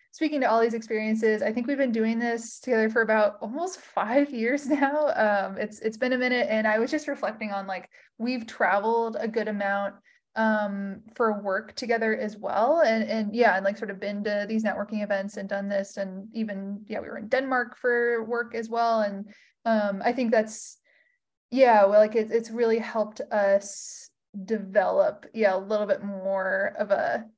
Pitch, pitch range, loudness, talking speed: 220 Hz, 205-240 Hz, -26 LUFS, 195 wpm